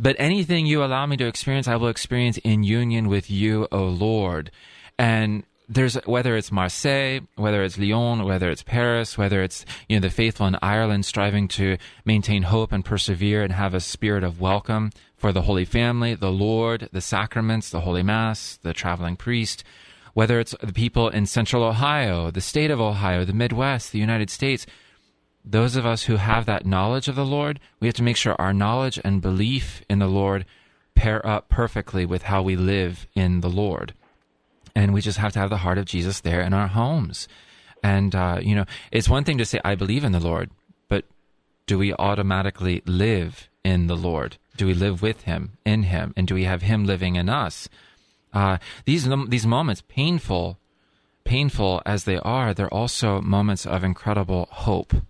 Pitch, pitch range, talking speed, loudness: 105 Hz, 95-115 Hz, 190 wpm, -23 LUFS